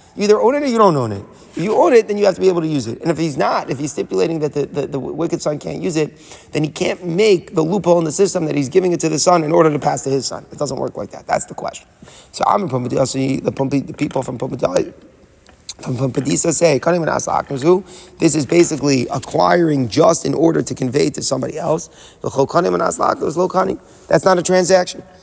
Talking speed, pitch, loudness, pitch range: 235 wpm, 165 Hz, -17 LUFS, 140-180 Hz